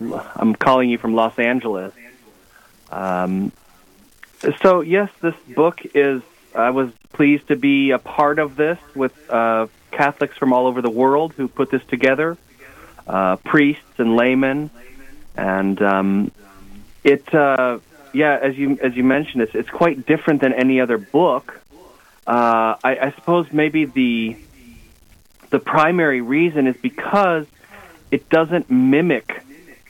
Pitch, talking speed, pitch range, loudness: 130 Hz, 140 wpm, 115-150 Hz, -18 LUFS